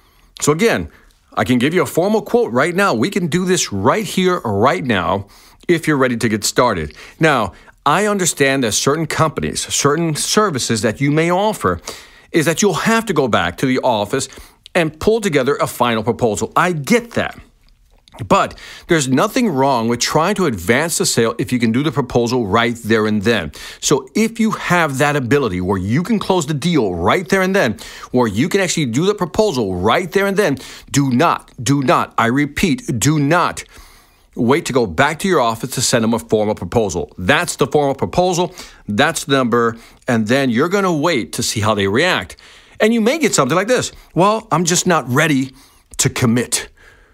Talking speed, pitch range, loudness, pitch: 200 wpm, 120-185 Hz, -16 LUFS, 150 Hz